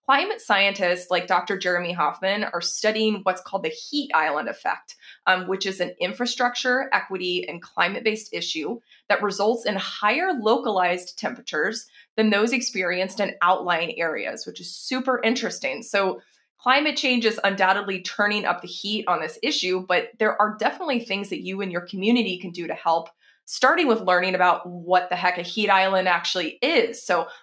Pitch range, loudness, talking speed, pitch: 180-230 Hz, -23 LUFS, 175 wpm, 200 Hz